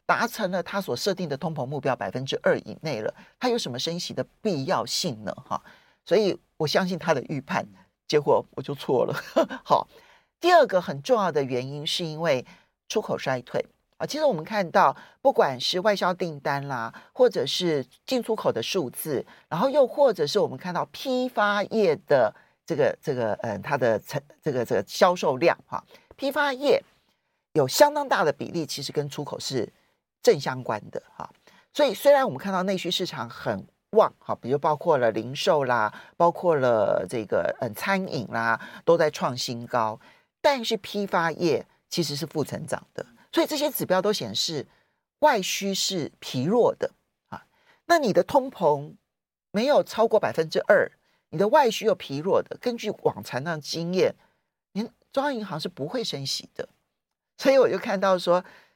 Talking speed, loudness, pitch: 260 characters per minute, -25 LUFS, 195 Hz